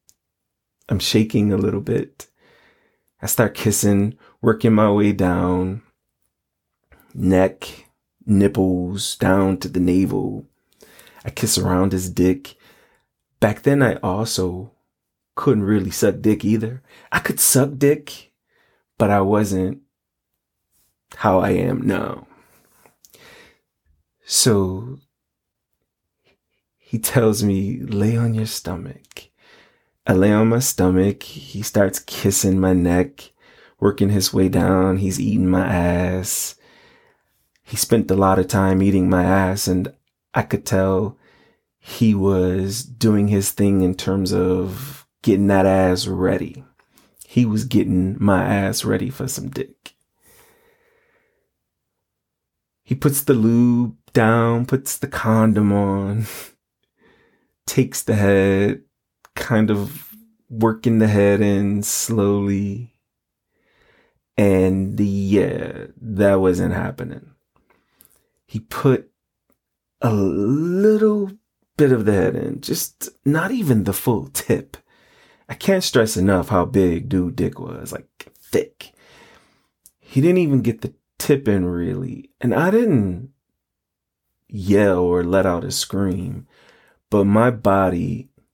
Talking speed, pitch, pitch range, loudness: 115 wpm, 100 Hz, 95-120 Hz, -19 LUFS